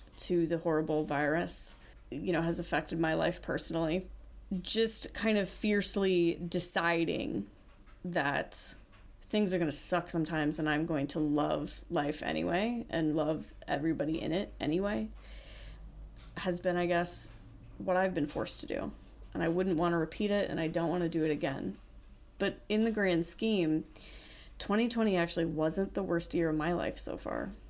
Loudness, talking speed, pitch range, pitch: -32 LUFS, 160 wpm, 155-185 Hz, 170 Hz